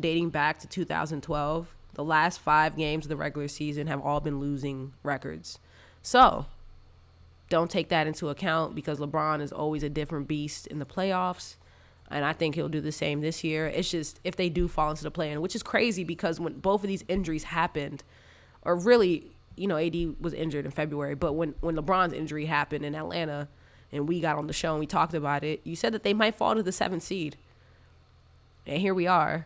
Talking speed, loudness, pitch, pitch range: 210 wpm, -29 LUFS, 155 Hz, 145-170 Hz